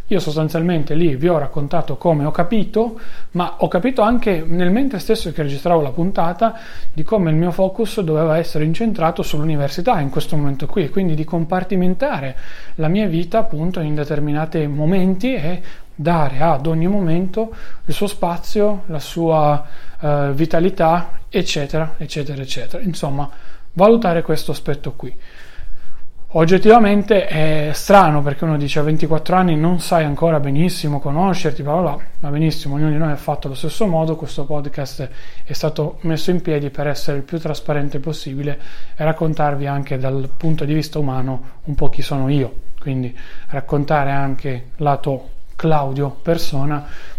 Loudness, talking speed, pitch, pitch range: -19 LUFS, 155 wpm, 155 Hz, 145-175 Hz